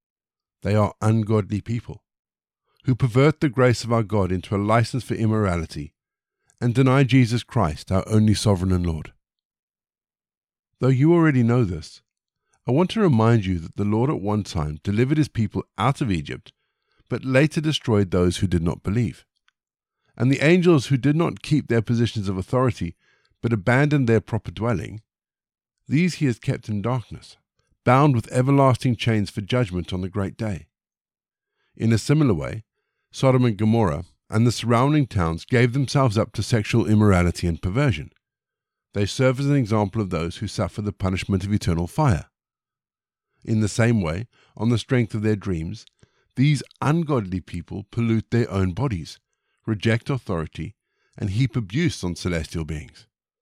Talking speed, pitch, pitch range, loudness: 165 wpm, 110 Hz, 100-130 Hz, -22 LUFS